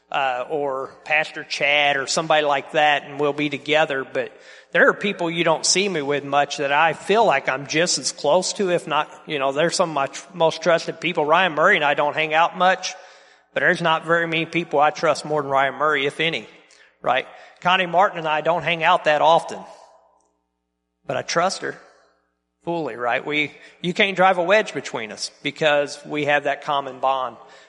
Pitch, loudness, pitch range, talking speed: 155 Hz, -20 LUFS, 145-170 Hz, 205 wpm